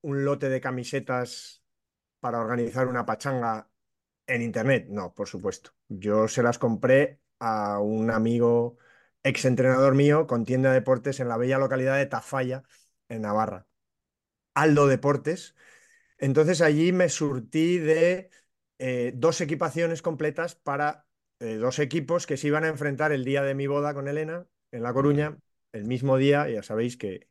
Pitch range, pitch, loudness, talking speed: 120-150 Hz, 135 Hz, -26 LUFS, 155 wpm